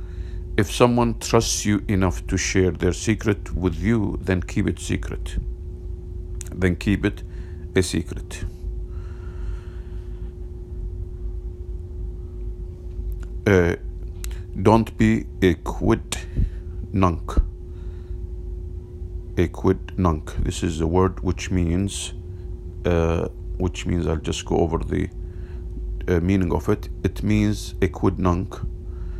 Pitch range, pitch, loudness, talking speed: 90-95 Hz, 90 Hz, -24 LUFS, 105 wpm